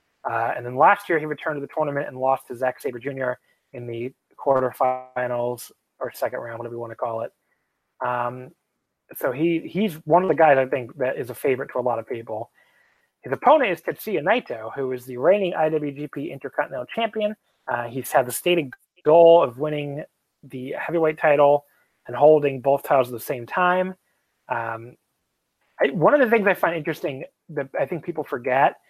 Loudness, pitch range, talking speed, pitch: -22 LUFS, 125-165 Hz, 190 wpm, 145 Hz